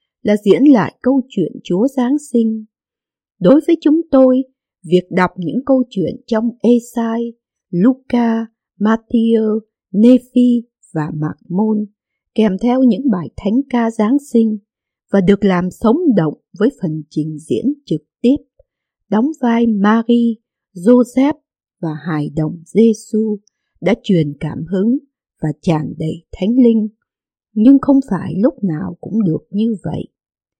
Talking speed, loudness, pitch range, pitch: 135 wpm, -15 LUFS, 185-250 Hz, 220 Hz